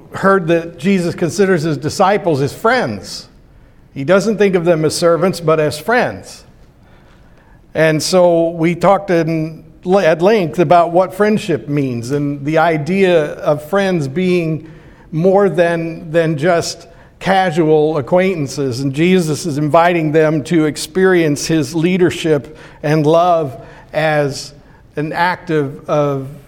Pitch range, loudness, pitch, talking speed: 150-180 Hz, -14 LUFS, 165 Hz, 130 wpm